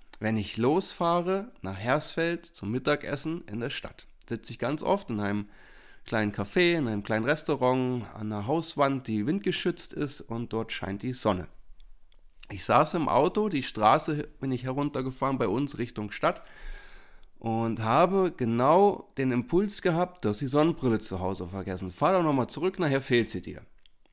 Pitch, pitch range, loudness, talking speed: 130 Hz, 105-160 Hz, -28 LUFS, 165 wpm